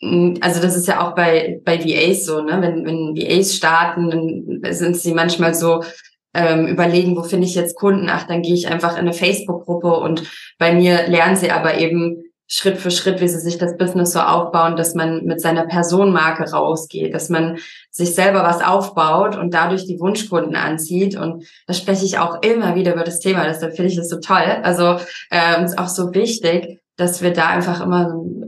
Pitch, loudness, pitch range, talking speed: 175 Hz, -17 LUFS, 165-180 Hz, 205 wpm